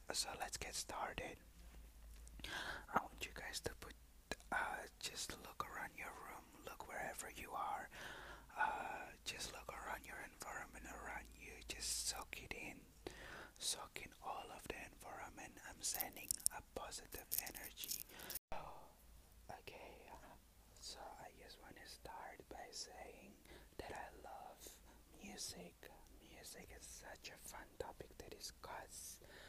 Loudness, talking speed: -49 LUFS, 130 wpm